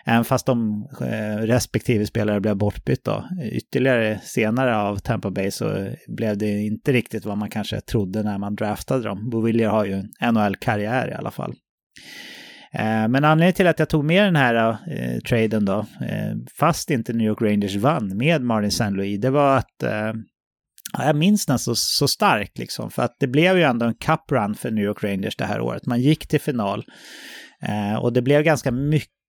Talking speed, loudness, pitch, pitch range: 185 wpm, -21 LUFS, 115 Hz, 105-130 Hz